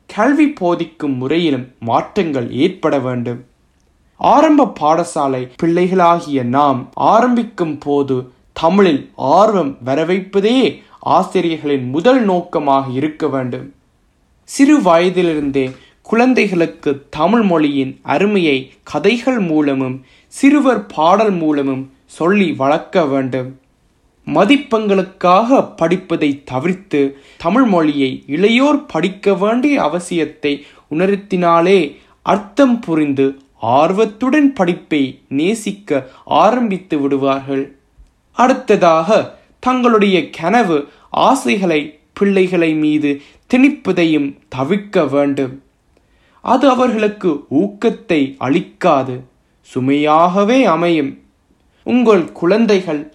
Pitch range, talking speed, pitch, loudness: 140-205 Hz, 75 wpm, 165 Hz, -14 LUFS